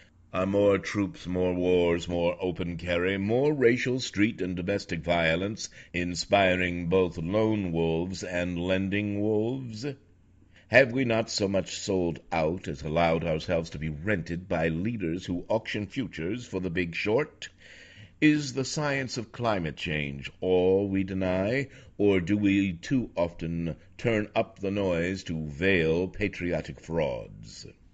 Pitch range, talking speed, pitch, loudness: 85-105 Hz, 140 wpm, 95 Hz, -28 LUFS